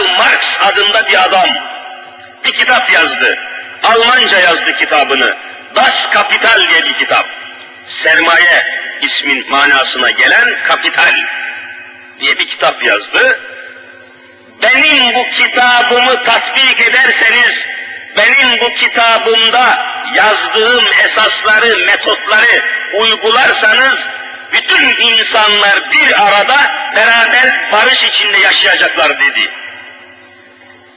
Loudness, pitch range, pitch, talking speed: -7 LUFS, 240-395 Hz, 380 Hz, 85 wpm